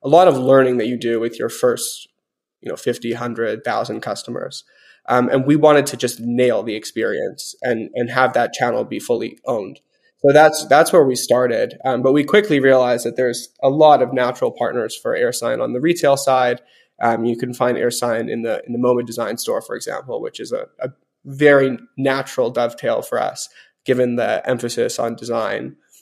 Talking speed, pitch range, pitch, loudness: 195 wpm, 120-170 Hz, 135 Hz, -18 LUFS